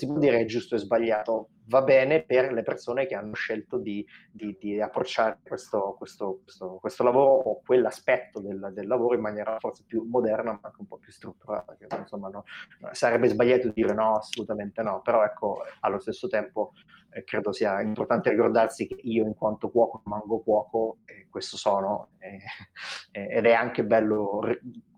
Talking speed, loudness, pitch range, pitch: 180 wpm, -26 LUFS, 105-120 Hz, 110 Hz